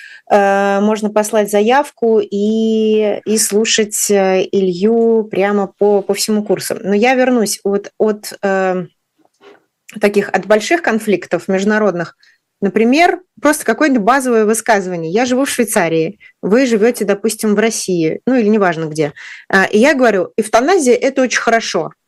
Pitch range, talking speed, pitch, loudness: 195-230 Hz, 130 wpm, 215 Hz, -14 LUFS